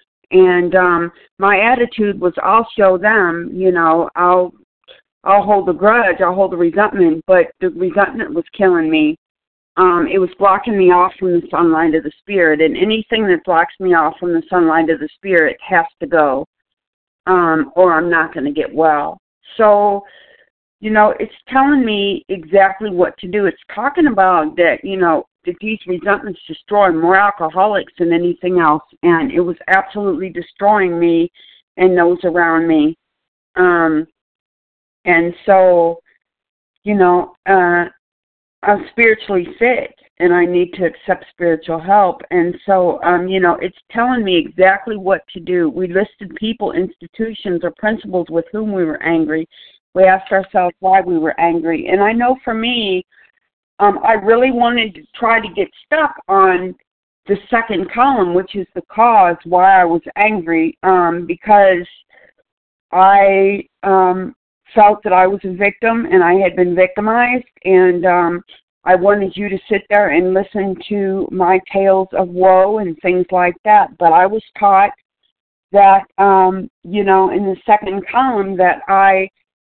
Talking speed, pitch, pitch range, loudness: 160 wpm, 190 Hz, 175-205 Hz, -14 LUFS